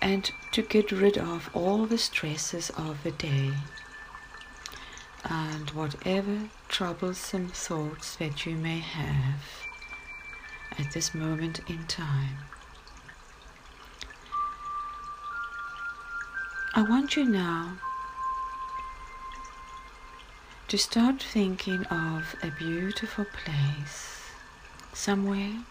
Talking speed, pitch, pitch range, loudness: 85 wpm, 195 Hz, 160-235 Hz, -31 LUFS